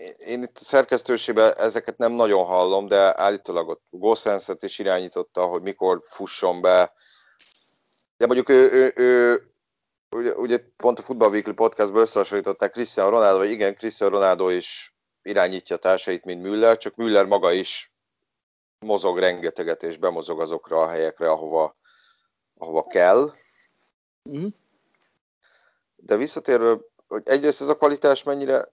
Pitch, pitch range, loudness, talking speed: 120 Hz, 100-140 Hz, -21 LUFS, 125 wpm